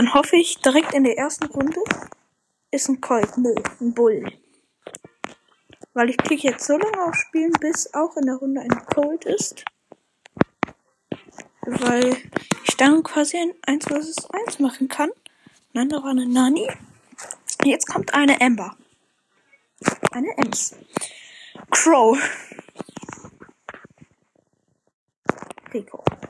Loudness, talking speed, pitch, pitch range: -21 LUFS, 120 wpm, 280 Hz, 255-320 Hz